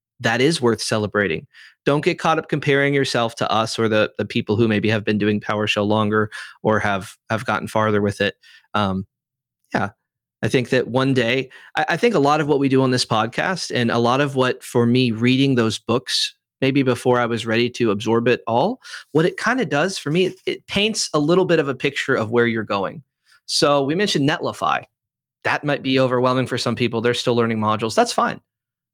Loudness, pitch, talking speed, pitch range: -20 LUFS, 120 Hz, 220 wpm, 110-145 Hz